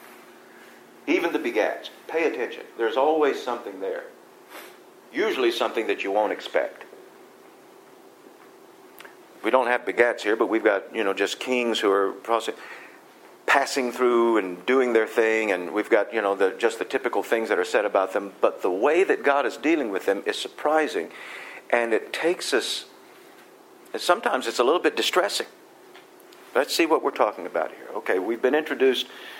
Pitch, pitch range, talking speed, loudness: 390 Hz, 355-440 Hz, 170 wpm, -24 LUFS